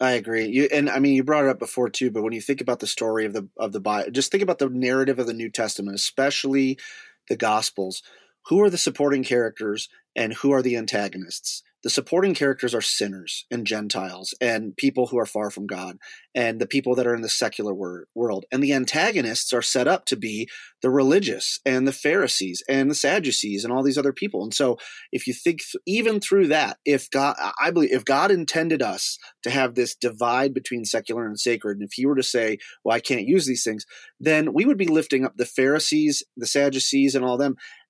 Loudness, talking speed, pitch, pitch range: -23 LUFS, 220 wpm, 125 Hz, 110-140 Hz